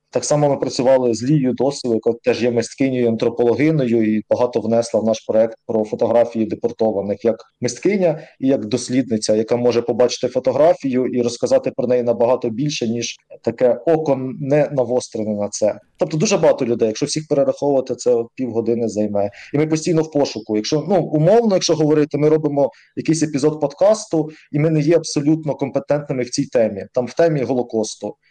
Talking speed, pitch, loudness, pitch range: 170 wpm, 130 Hz, -18 LUFS, 115-150 Hz